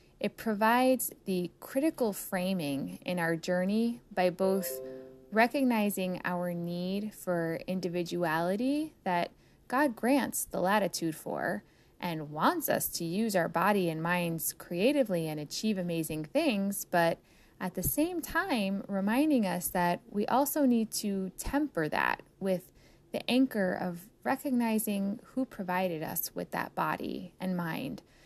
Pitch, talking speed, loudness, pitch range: 190 Hz, 130 wpm, -31 LUFS, 175-235 Hz